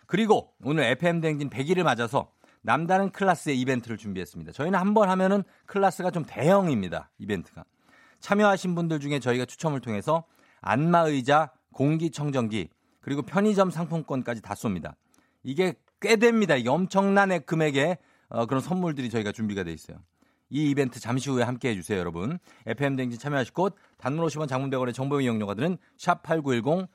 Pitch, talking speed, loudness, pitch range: 145 Hz, 380 characters per minute, -26 LUFS, 125-180 Hz